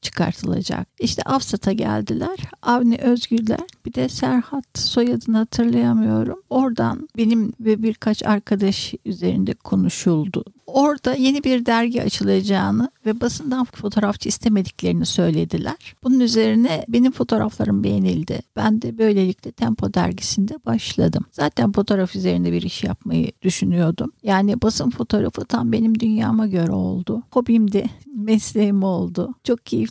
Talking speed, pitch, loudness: 120 wpm, 210 Hz, -20 LUFS